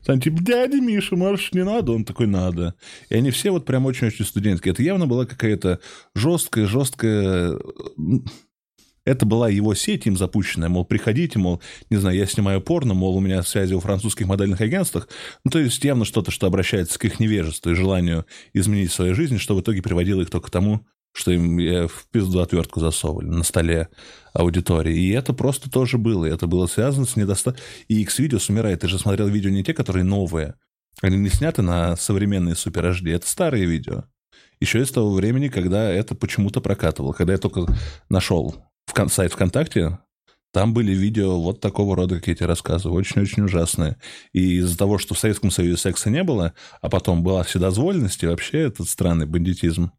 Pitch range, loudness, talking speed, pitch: 90-115 Hz, -21 LUFS, 180 wpm, 100 Hz